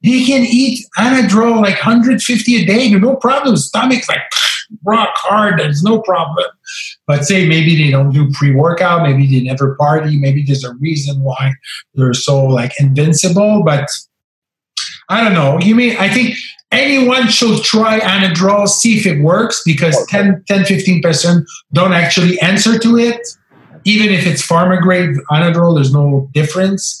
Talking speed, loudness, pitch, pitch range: 160 wpm, -11 LUFS, 185 Hz, 150-225 Hz